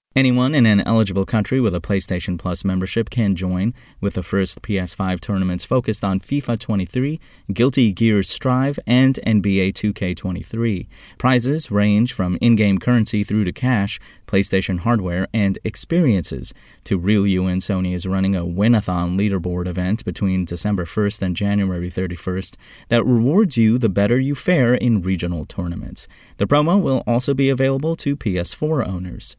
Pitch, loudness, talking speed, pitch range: 100 Hz, -19 LUFS, 155 wpm, 95-120 Hz